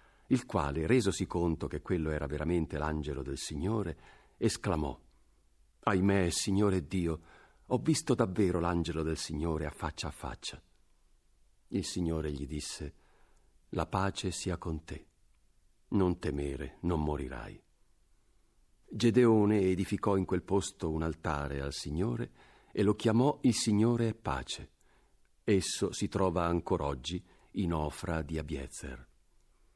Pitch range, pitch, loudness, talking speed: 75-100 Hz, 85 Hz, -33 LUFS, 125 wpm